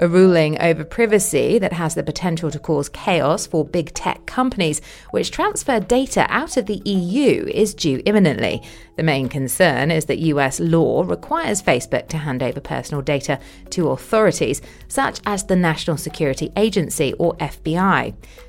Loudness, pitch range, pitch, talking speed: -19 LUFS, 150-205 Hz, 165 Hz, 160 wpm